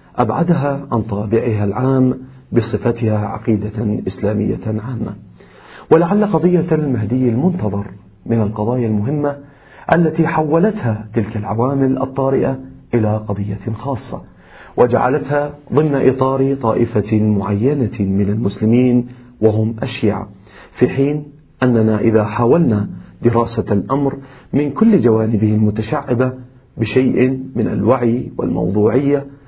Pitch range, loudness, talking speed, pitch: 110-135 Hz, -16 LUFS, 95 wpm, 120 Hz